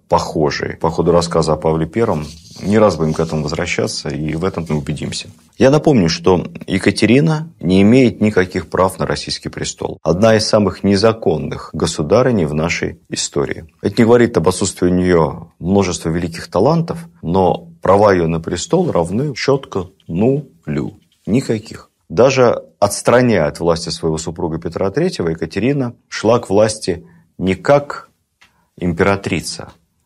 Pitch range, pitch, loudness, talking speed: 80-110 Hz, 90 Hz, -16 LUFS, 140 wpm